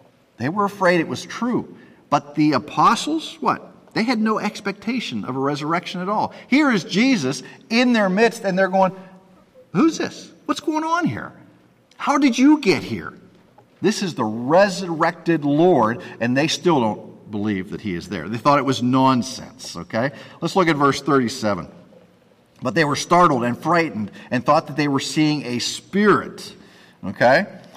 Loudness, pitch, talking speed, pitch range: -20 LUFS, 170 Hz, 170 wpm, 135-205 Hz